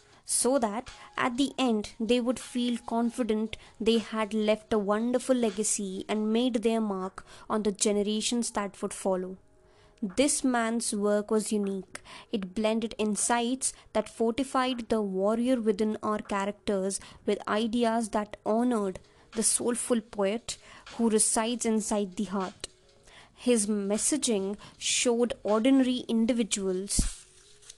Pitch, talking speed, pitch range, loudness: 220 Hz, 125 wpm, 210-240 Hz, -28 LUFS